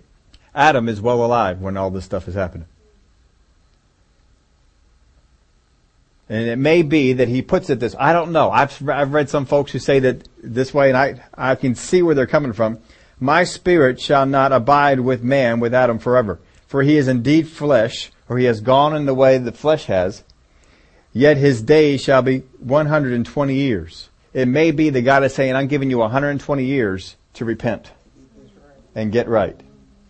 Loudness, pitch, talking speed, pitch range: -17 LUFS, 125 Hz, 180 wpm, 95-140 Hz